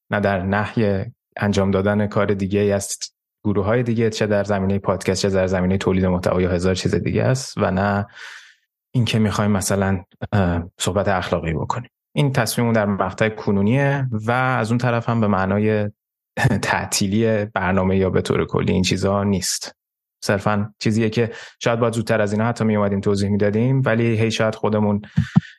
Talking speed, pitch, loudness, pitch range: 165 wpm, 105 Hz, -20 LUFS, 100-110 Hz